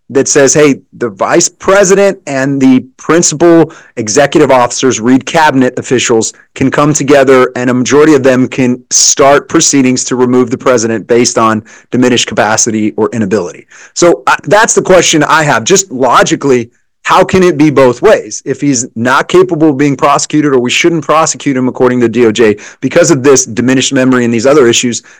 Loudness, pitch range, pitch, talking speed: -8 LUFS, 125-155 Hz, 130 Hz, 180 wpm